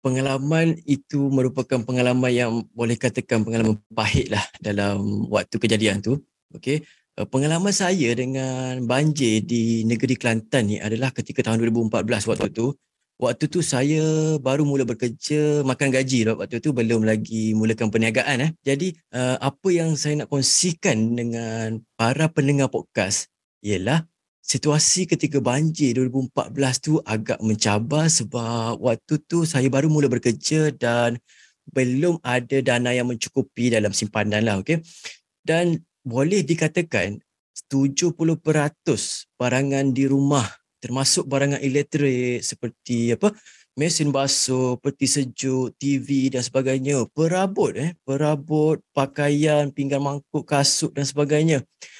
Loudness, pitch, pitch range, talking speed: -22 LUFS, 135 Hz, 120-150 Hz, 125 wpm